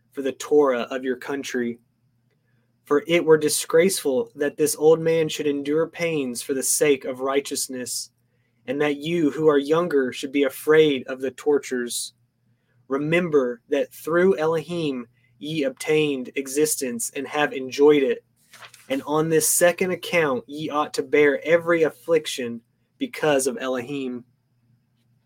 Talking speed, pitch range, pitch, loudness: 140 wpm, 125-155 Hz, 140 Hz, -22 LUFS